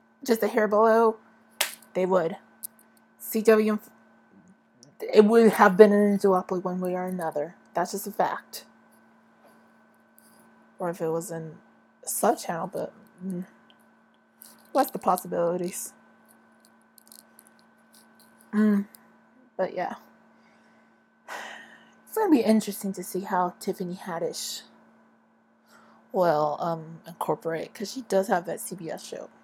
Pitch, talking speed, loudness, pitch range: 195 Hz, 115 wpm, -25 LUFS, 180-215 Hz